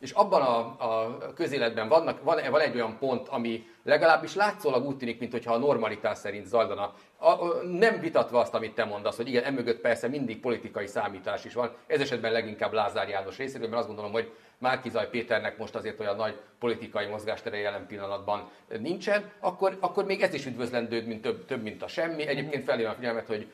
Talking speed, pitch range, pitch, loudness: 190 wpm, 110-155 Hz, 120 Hz, -29 LUFS